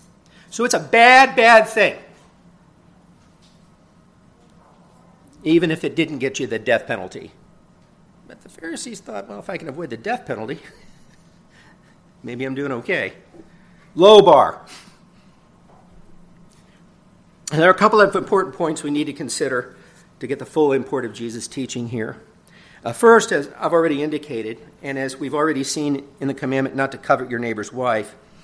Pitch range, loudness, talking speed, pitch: 135-180 Hz, -18 LUFS, 155 wpm, 150 Hz